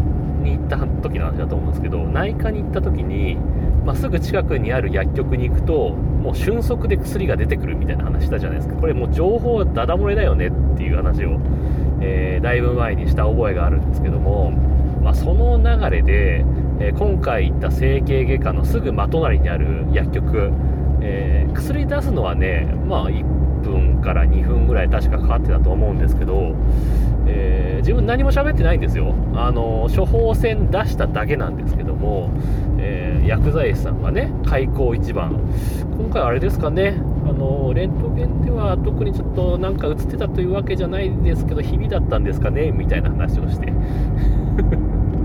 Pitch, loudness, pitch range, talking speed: 70 Hz, -19 LUFS, 65-75 Hz, 335 characters per minute